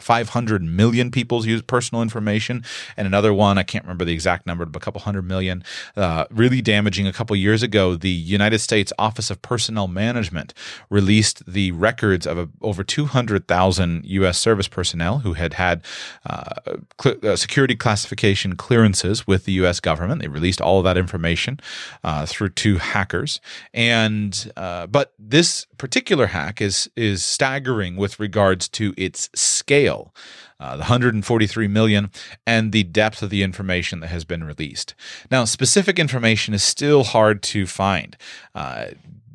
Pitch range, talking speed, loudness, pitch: 95-115 Hz, 160 wpm, -20 LUFS, 105 Hz